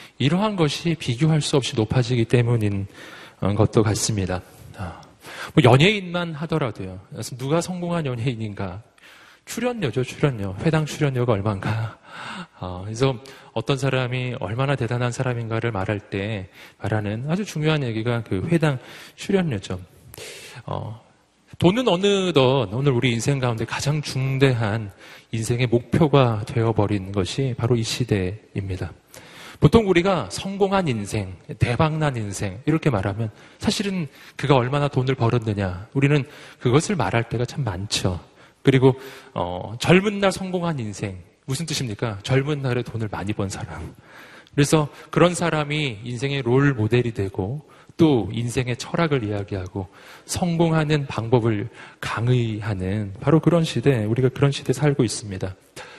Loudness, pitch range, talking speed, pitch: -22 LUFS, 110-150 Hz, 295 characters per minute, 125 Hz